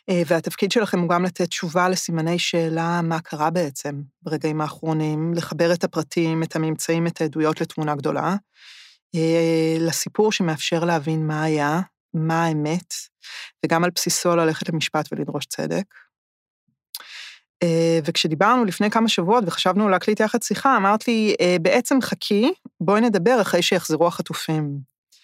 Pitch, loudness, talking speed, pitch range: 170 Hz, -21 LUFS, 125 wpm, 160-190 Hz